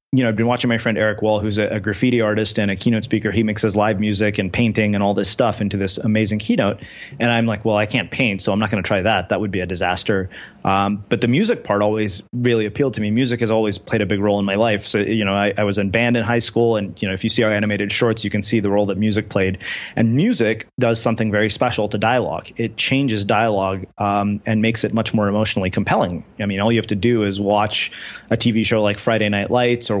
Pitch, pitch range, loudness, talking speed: 110 Hz, 105-115 Hz, -19 LUFS, 270 wpm